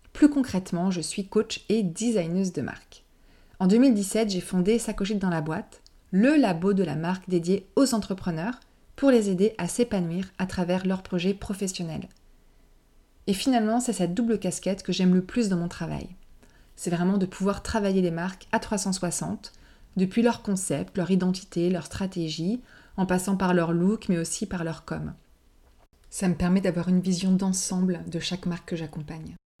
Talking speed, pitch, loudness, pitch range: 175 wpm, 185 Hz, -26 LUFS, 175-210 Hz